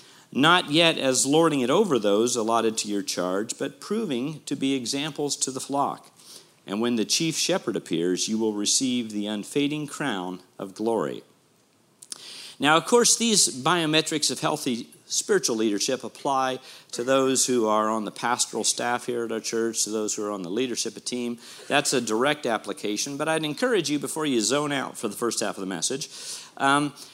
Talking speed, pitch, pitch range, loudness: 185 wpm, 130 Hz, 110-150 Hz, -24 LUFS